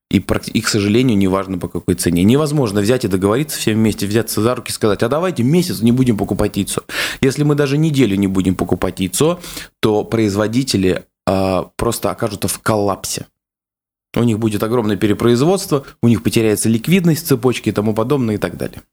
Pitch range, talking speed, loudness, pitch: 100-130 Hz, 180 wpm, -16 LUFS, 110 Hz